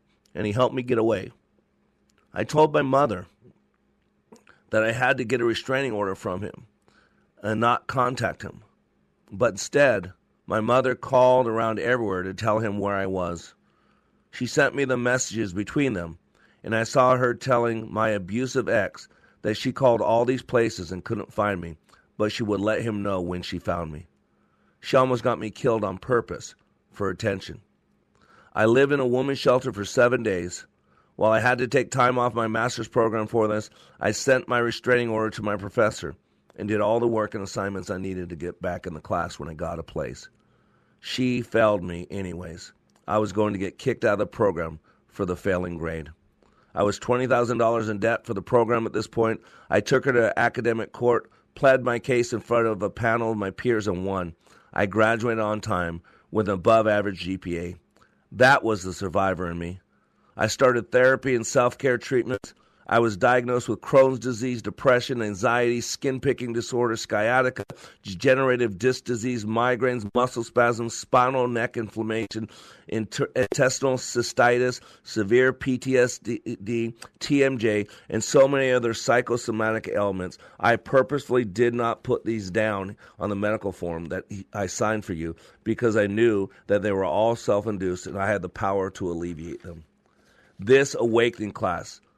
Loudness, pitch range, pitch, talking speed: -24 LUFS, 95-125 Hz, 110 Hz, 175 wpm